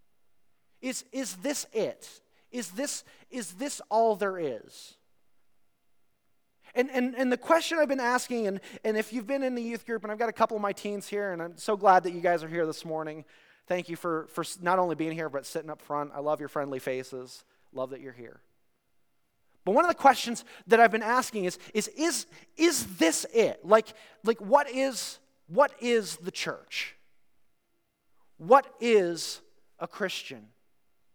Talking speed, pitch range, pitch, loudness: 185 wpm, 165-250 Hz, 215 Hz, -28 LUFS